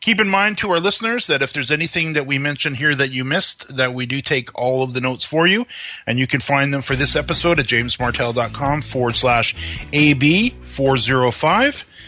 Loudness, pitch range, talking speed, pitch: -17 LUFS, 130-165 Hz, 200 wpm, 140 Hz